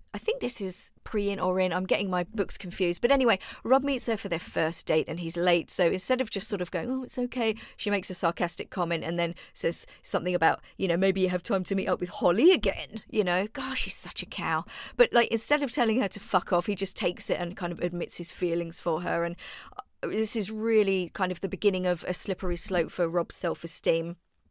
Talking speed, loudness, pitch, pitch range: 245 wpm, -28 LUFS, 185 Hz, 175-220 Hz